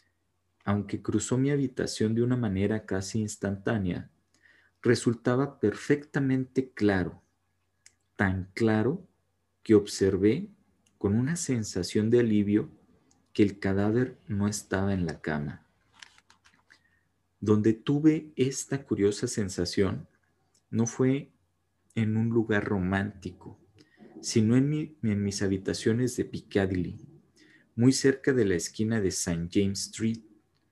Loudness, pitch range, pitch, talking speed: -28 LUFS, 95-125 Hz, 105 Hz, 110 wpm